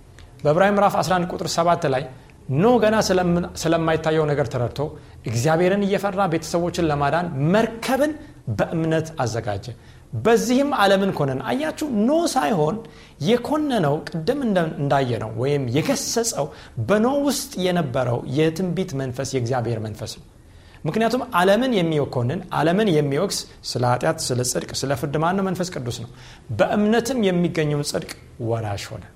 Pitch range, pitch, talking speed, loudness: 130-200 Hz, 160 Hz, 115 wpm, -21 LUFS